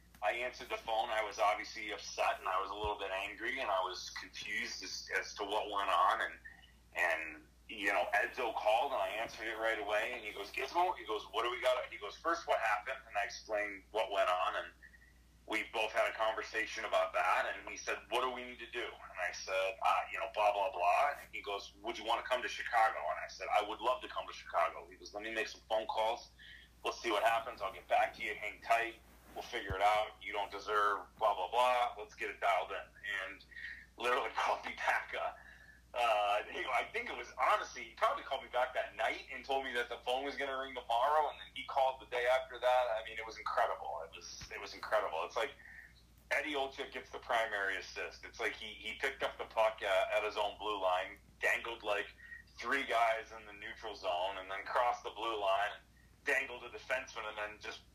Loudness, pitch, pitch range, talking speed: -36 LUFS, 110 Hz, 100-125 Hz, 235 wpm